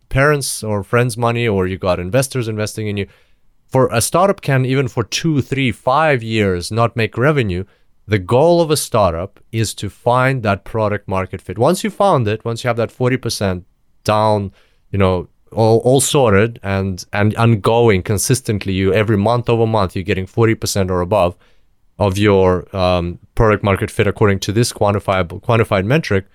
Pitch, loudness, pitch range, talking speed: 110 Hz, -16 LUFS, 95-120 Hz, 175 wpm